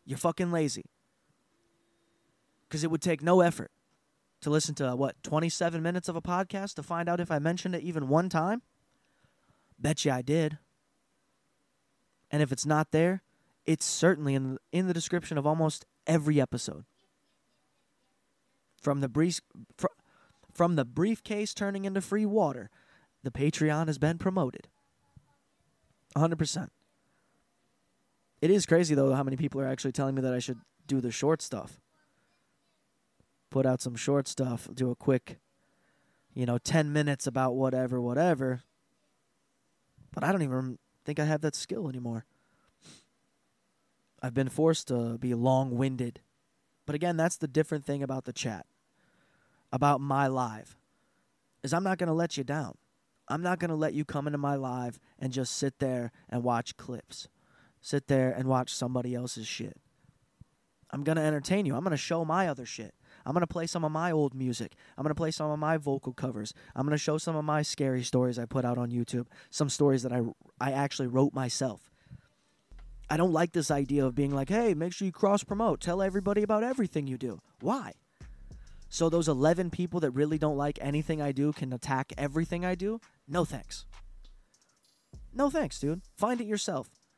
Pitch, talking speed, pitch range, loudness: 150 Hz, 175 wpm, 130-170 Hz, -30 LUFS